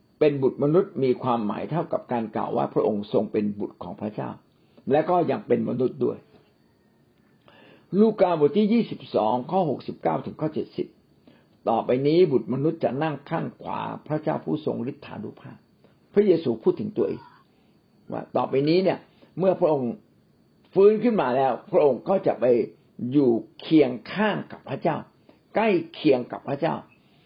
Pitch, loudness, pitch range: 155 Hz, -24 LUFS, 130-185 Hz